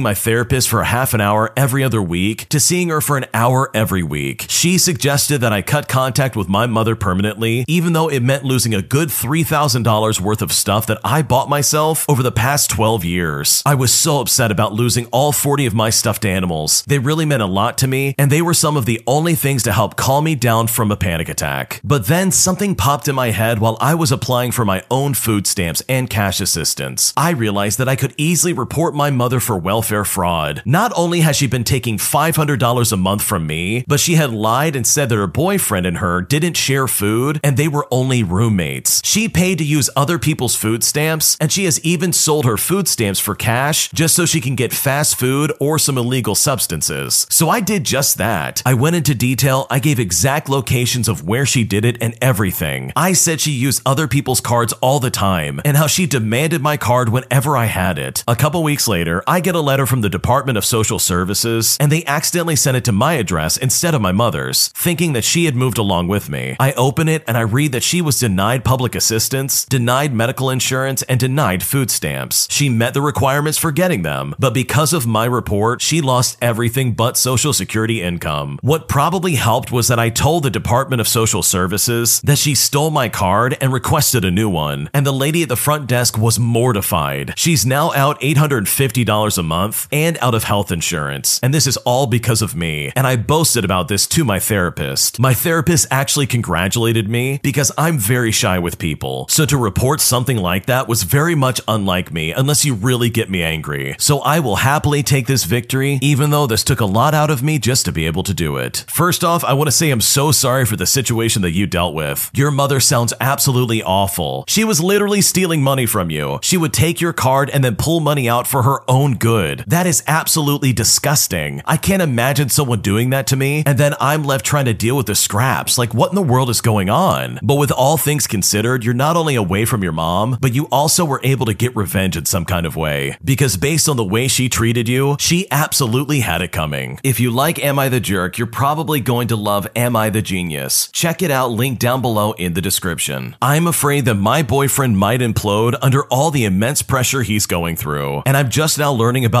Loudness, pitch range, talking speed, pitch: -15 LUFS, 110-145 Hz, 220 wpm, 125 Hz